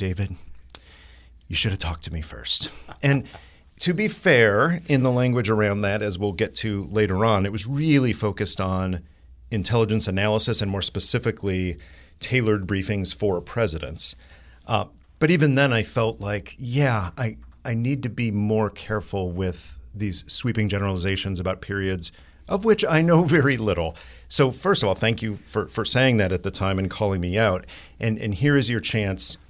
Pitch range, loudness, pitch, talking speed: 90-115 Hz, -22 LUFS, 105 Hz, 175 wpm